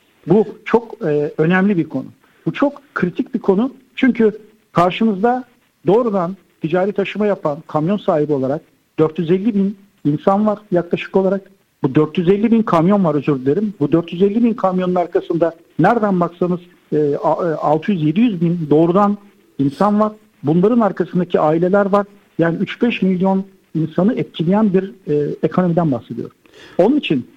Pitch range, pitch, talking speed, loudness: 165-210 Hz, 190 Hz, 135 wpm, -17 LUFS